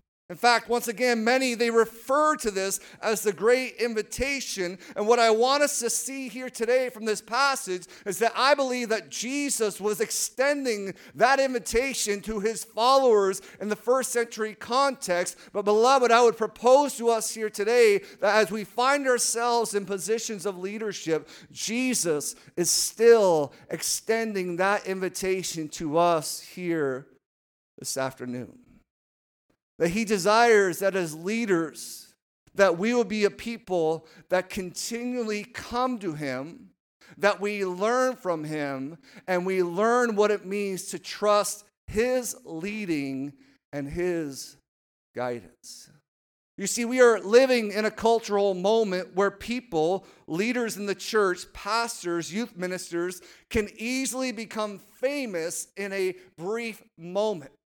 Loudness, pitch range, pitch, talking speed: -25 LUFS, 180-235 Hz, 210 Hz, 140 wpm